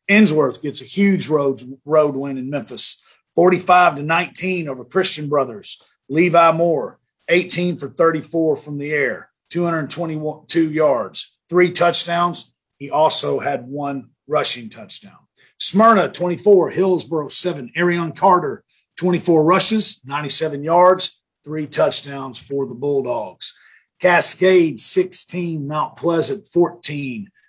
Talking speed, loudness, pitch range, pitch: 115 wpm, -18 LUFS, 145-180 Hz, 165 Hz